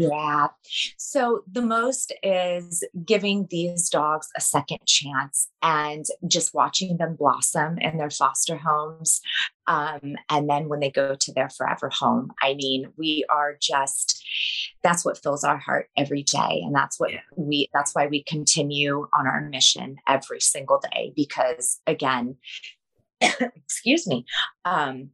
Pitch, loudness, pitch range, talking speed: 150 Hz, -23 LUFS, 140-170 Hz, 145 wpm